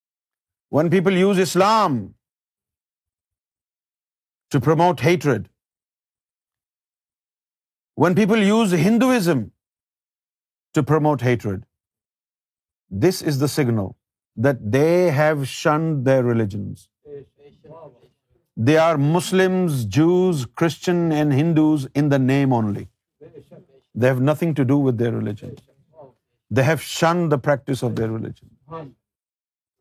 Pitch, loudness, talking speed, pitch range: 140 Hz, -19 LUFS, 95 wpm, 110-160 Hz